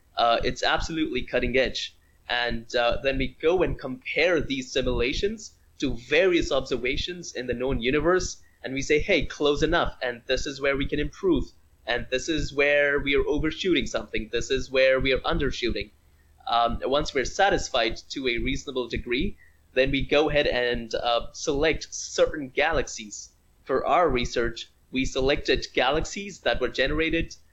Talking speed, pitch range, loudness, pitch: 160 wpm, 120-150 Hz, -25 LUFS, 130 Hz